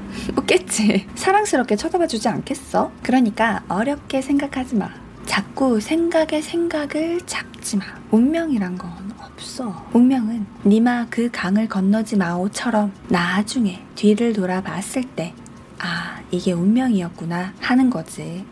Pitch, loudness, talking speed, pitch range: 225 Hz, -20 LUFS, 270 characters per minute, 200-265 Hz